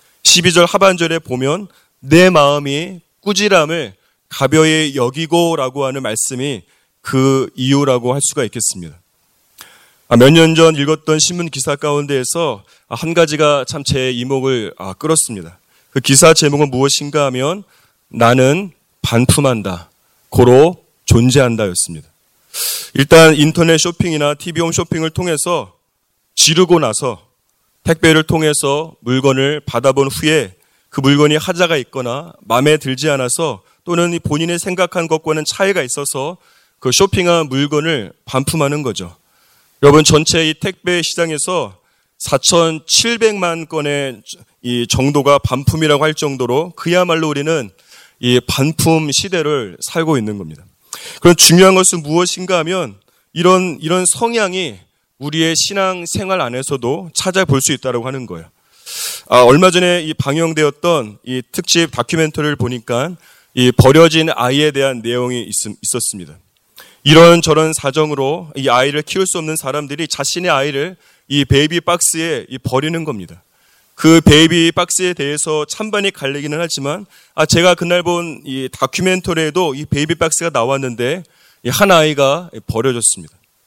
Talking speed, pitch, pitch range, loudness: 295 characters per minute, 150 Hz, 130-170 Hz, -13 LUFS